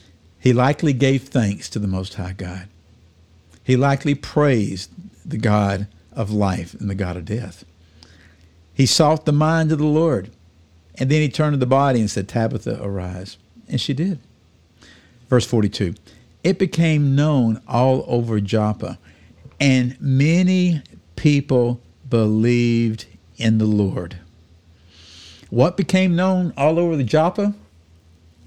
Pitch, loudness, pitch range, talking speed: 110 Hz, -19 LUFS, 90-140 Hz, 135 wpm